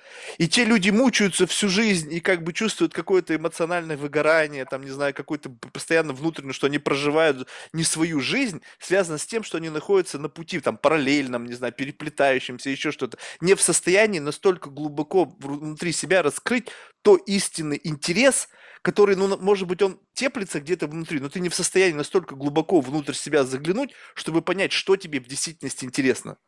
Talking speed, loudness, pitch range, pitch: 170 wpm, -23 LUFS, 145-195 Hz, 165 Hz